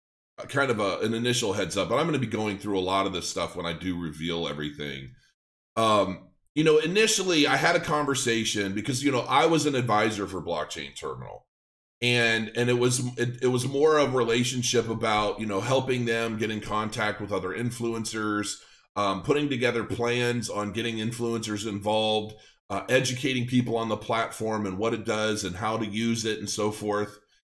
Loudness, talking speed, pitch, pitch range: -26 LUFS, 195 wpm, 110 Hz, 105-125 Hz